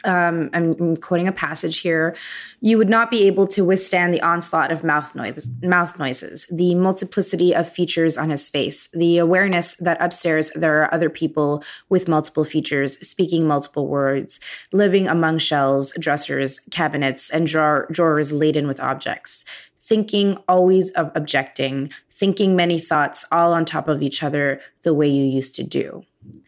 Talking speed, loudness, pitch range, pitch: 165 wpm, -19 LUFS, 150-180 Hz, 165 Hz